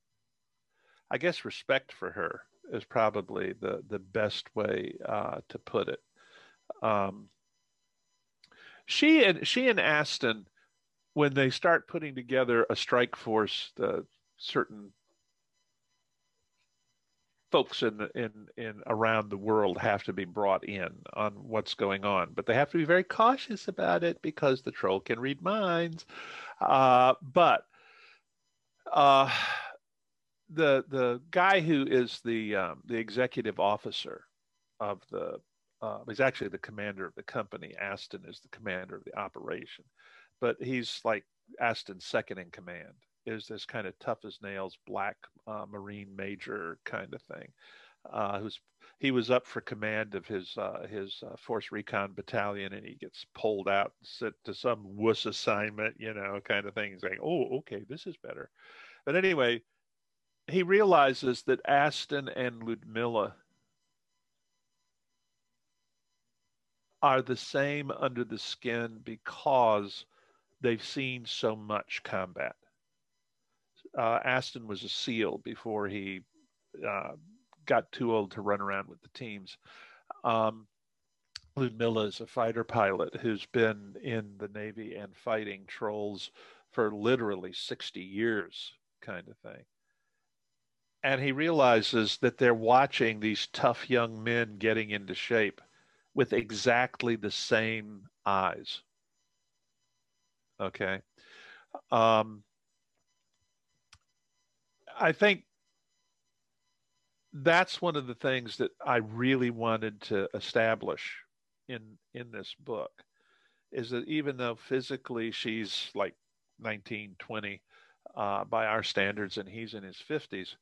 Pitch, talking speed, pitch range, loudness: 115 Hz, 130 wpm, 105-130 Hz, -31 LUFS